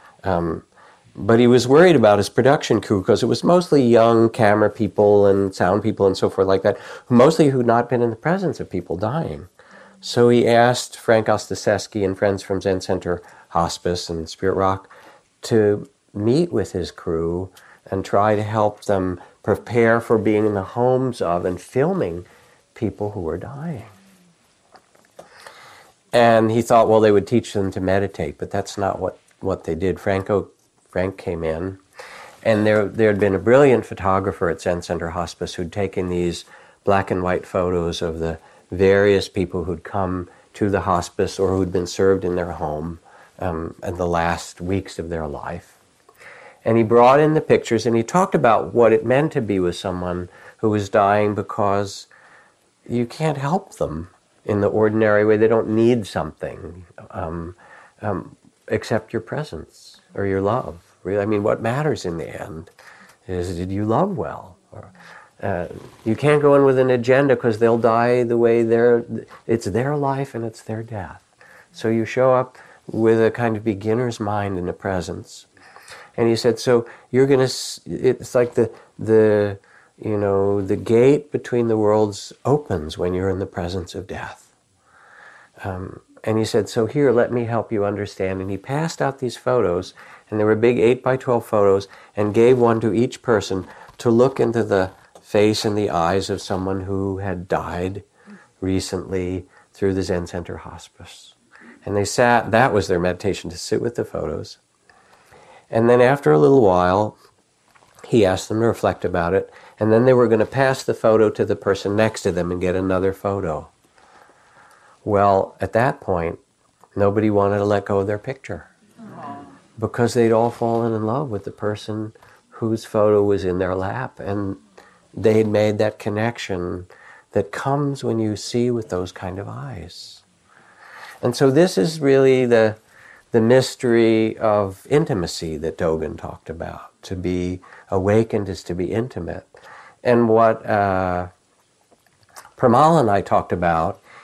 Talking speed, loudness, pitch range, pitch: 175 wpm, -19 LUFS, 95-115 Hz, 105 Hz